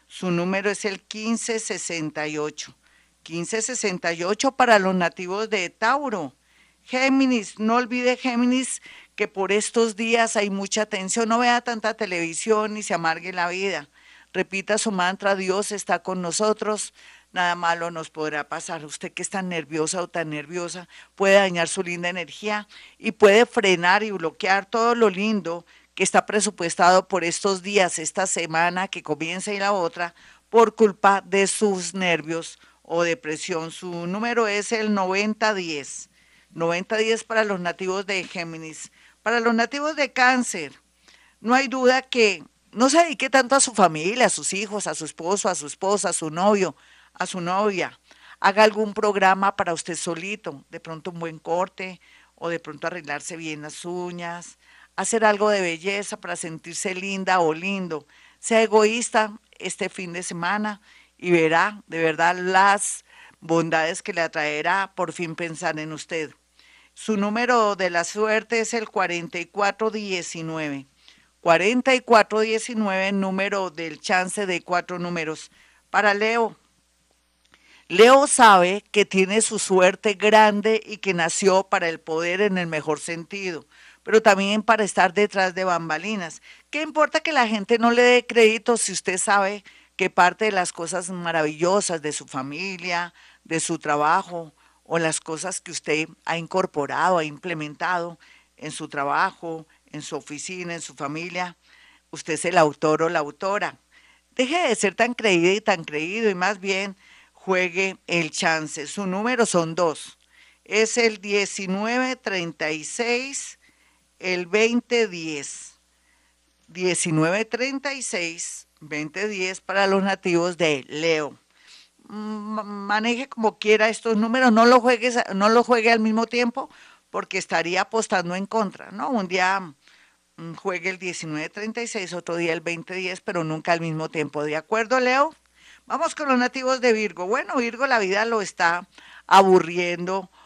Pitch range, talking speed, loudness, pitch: 170-215 Hz, 145 wpm, -22 LUFS, 190 Hz